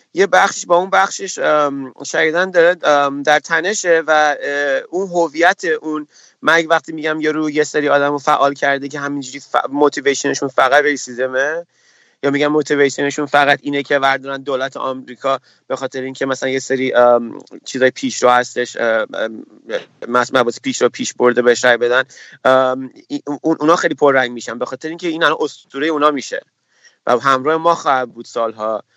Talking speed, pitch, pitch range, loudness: 150 wpm, 145 Hz, 130-160 Hz, -16 LUFS